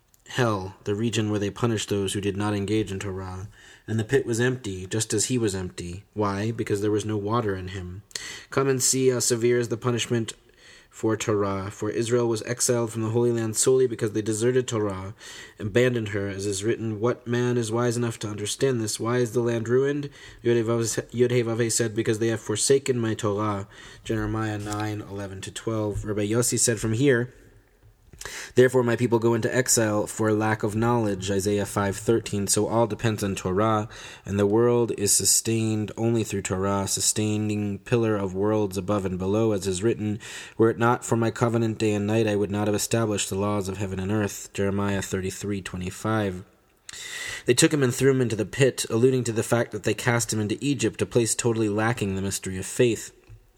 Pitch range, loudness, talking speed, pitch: 100-120 Hz, -25 LUFS, 195 wpm, 110 Hz